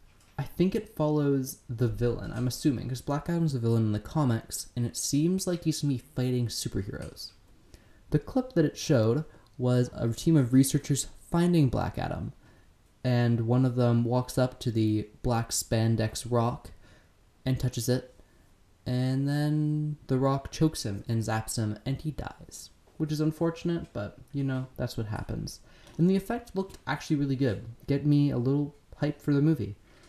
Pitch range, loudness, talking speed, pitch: 115-150 Hz, -29 LUFS, 175 wpm, 125 Hz